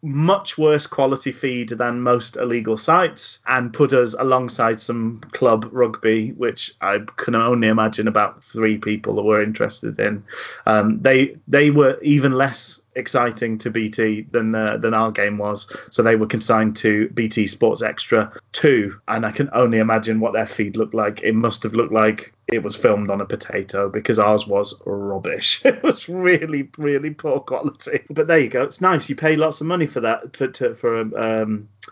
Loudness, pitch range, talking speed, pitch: -19 LUFS, 110-135 Hz, 185 wpm, 115 Hz